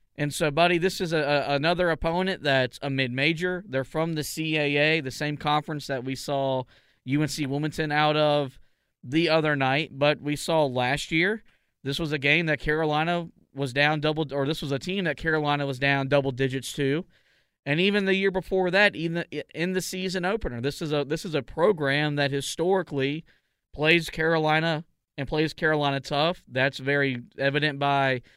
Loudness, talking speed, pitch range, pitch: -25 LUFS, 180 wpm, 140-165 Hz, 150 Hz